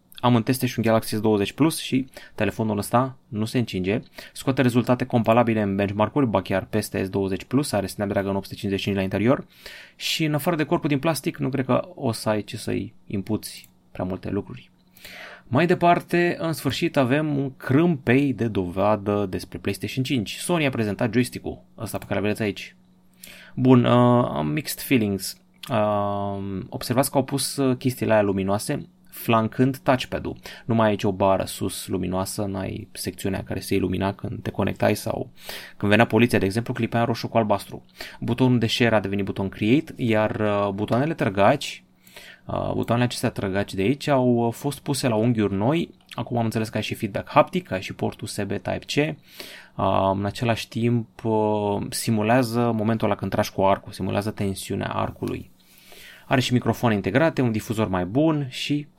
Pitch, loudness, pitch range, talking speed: 115 Hz, -23 LUFS, 100-130 Hz, 170 wpm